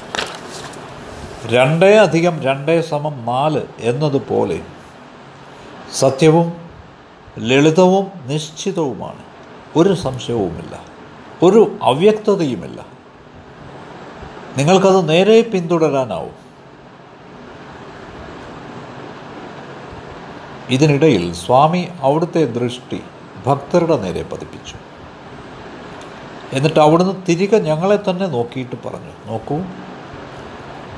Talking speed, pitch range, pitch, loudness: 60 wpm, 125-175 Hz, 155 Hz, -16 LUFS